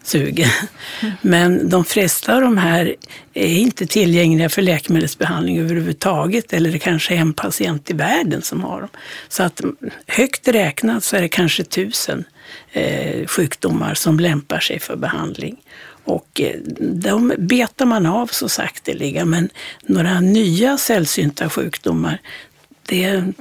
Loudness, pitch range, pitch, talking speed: -17 LUFS, 165-220 Hz, 180 Hz, 135 wpm